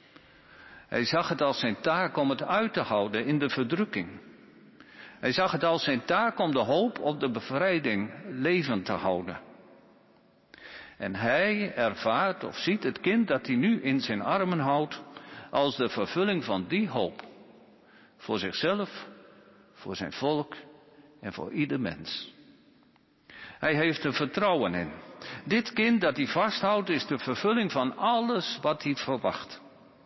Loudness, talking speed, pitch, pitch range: -28 LUFS, 150 wpm, 150 Hz, 135-195 Hz